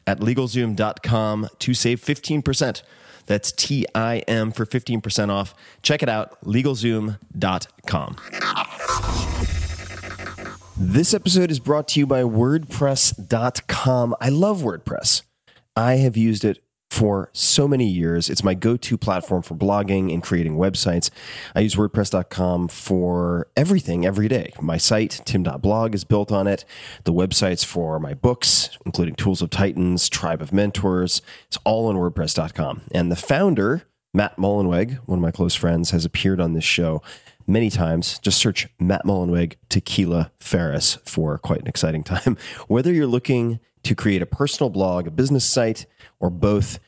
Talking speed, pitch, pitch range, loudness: 150 wpm, 100 Hz, 90-120 Hz, -21 LUFS